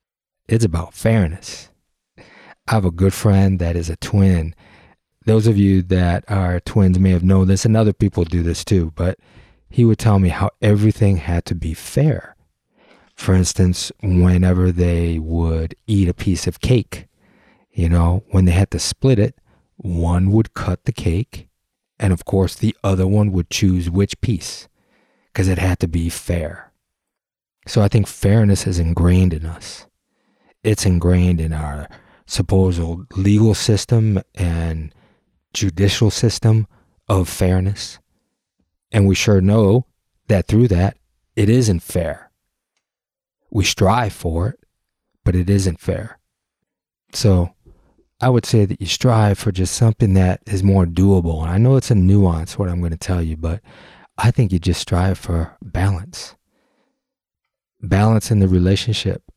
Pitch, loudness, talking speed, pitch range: 95 Hz, -17 LUFS, 155 wpm, 90-105 Hz